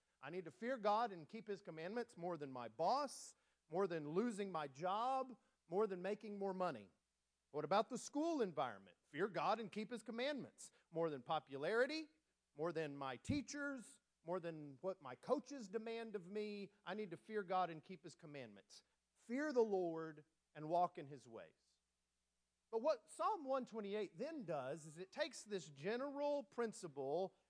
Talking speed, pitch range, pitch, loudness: 170 wpm, 155-235 Hz, 190 Hz, -45 LUFS